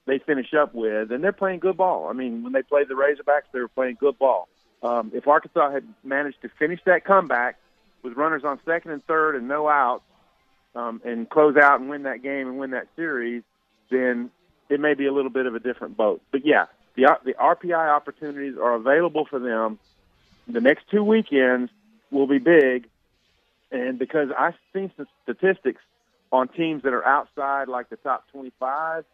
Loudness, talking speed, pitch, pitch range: -22 LUFS, 195 wpm, 140 Hz, 125-160 Hz